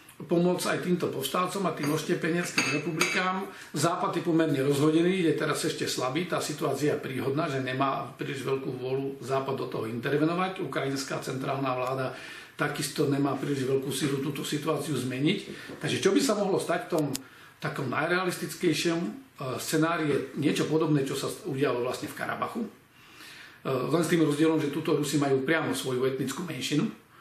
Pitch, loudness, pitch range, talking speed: 150 Hz, -28 LUFS, 135-170 Hz, 160 wpm